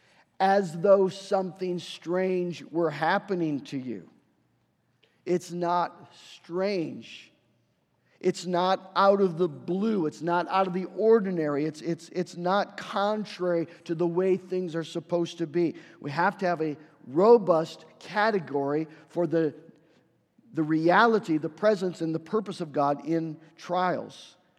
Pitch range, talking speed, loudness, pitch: 160-190 Hz, 135 wpm, -27 LUFS, 175 Hz